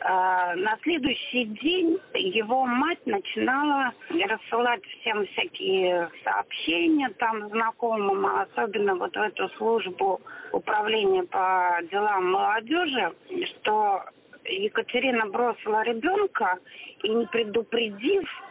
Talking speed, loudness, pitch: 90 wpm, -26 LUFS, 255 Hz